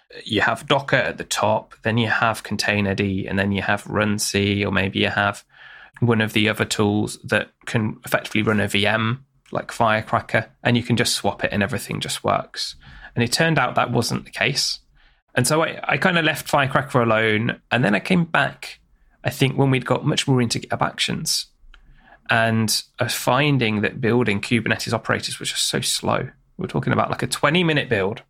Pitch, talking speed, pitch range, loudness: 115 Hz, 200 wpm, 105-130 Hz, -21 LUFS